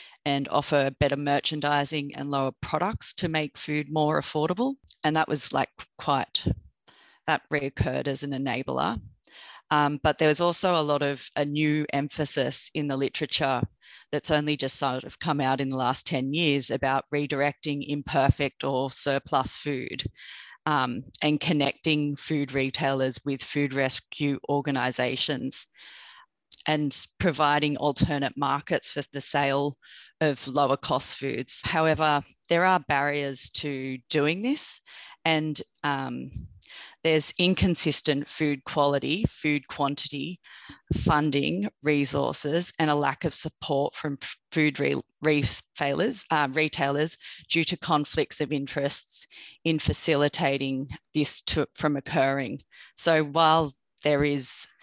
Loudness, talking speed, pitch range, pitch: -26 LUFS, 125 wpm, 140-155 Hz, 145 Hz